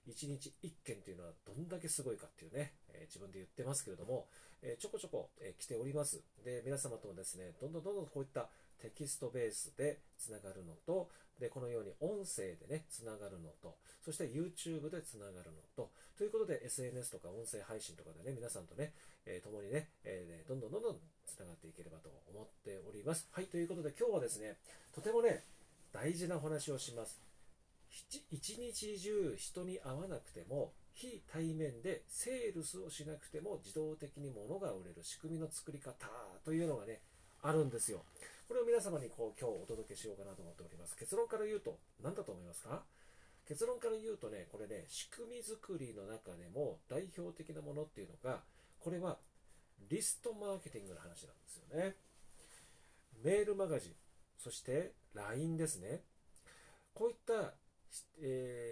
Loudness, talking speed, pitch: -44 LUFS, 380 characters per minute, 155 Hz